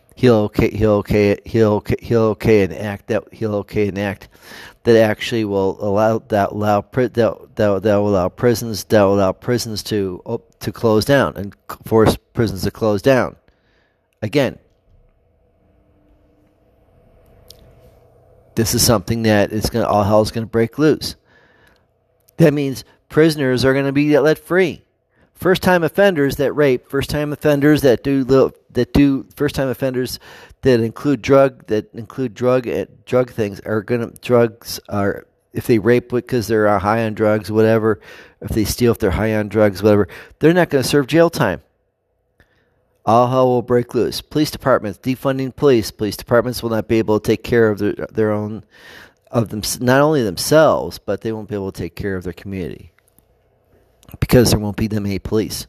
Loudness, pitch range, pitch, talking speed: -17 LUFS, 105-125 Hz, 115 Hz, 170 wpm